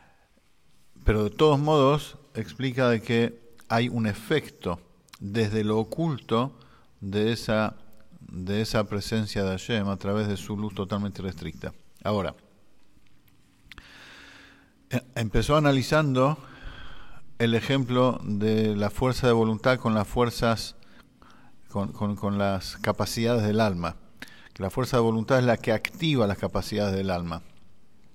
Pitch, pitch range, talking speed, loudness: 110 Hz, 100-125 Hz, 130 wpm, -26 LUFS